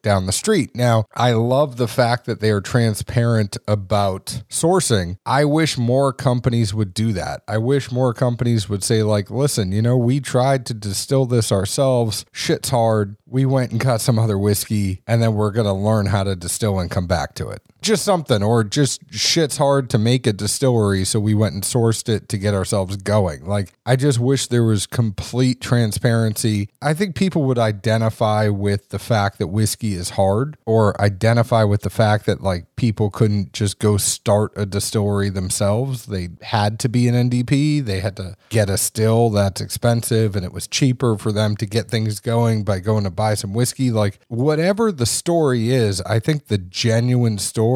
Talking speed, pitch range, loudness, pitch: 195 wpm, 105-125 Hz, -19 LUFS, 110 Hz